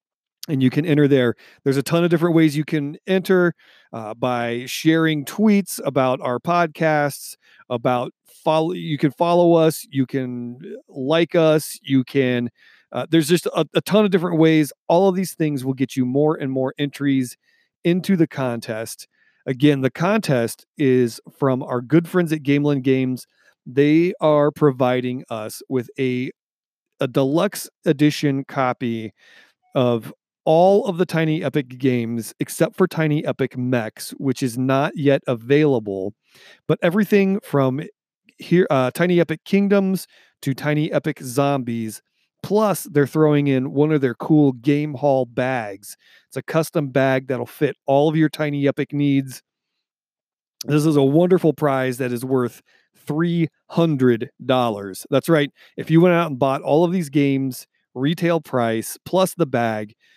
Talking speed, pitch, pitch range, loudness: 155 wpm, 145 Hz, 130-165 Hz, -20 LUFS